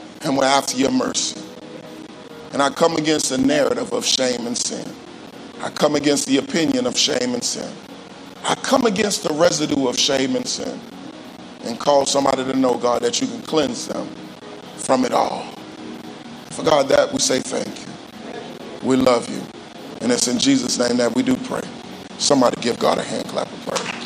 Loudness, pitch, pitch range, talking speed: -19 LUFS, 135 Hz, 125-175 Hz, 185 wpm